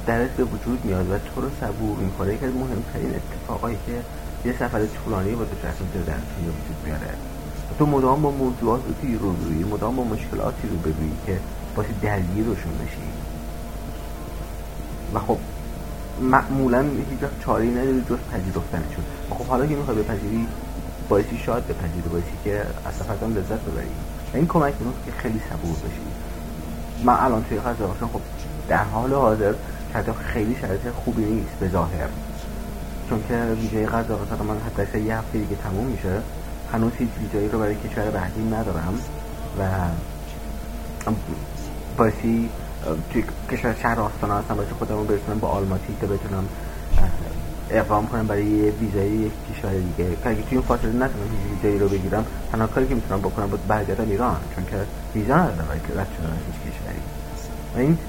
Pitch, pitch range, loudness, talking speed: 100 Hz, 80-110 Hz, -25 LUFS, 155 wpm